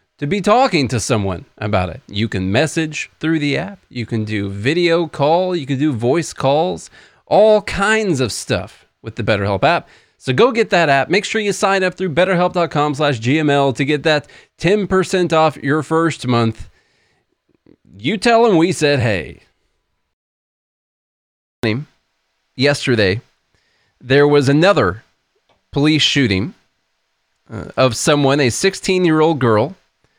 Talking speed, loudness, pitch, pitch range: 135 wpm, -16 LUFS, 145 Hz, 110-175 Hz